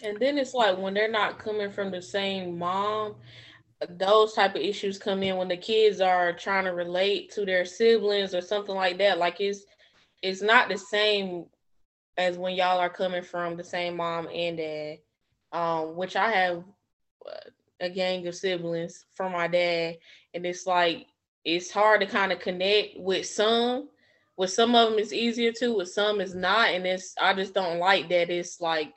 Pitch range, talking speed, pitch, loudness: 175-205 Hz, 190 wpm, 185 Hz, -26 LUFS